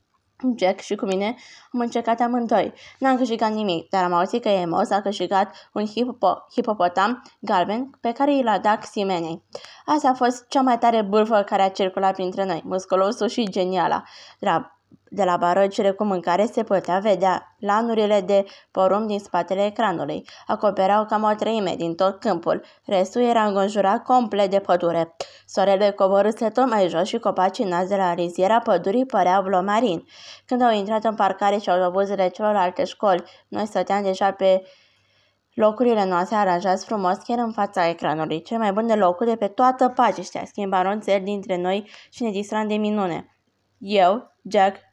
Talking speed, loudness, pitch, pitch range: 170 wpm, -22 LUFS, 200 Hz, 185-220 Hz